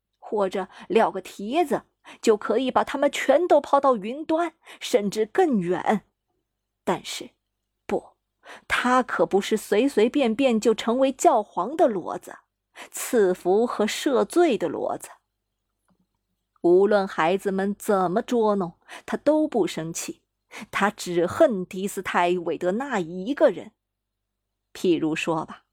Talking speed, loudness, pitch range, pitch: 185 characters per minute, -23 LUFS, 180-265 Hz, 210 Hz